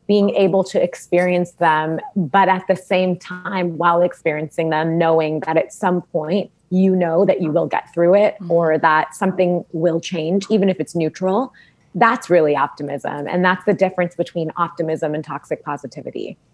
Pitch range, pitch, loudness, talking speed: 160-190 Hz, 175 Hz, -18 LUFS, 170 wpm